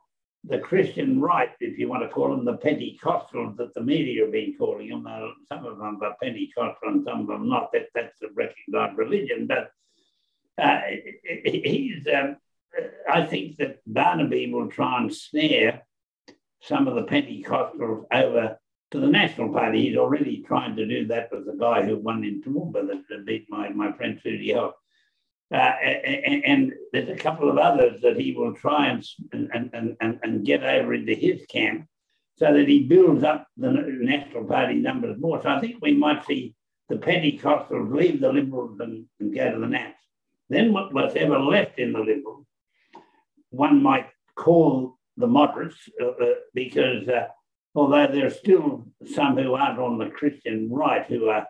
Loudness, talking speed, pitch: -23 LUFS, 175 wpm, 270 Hz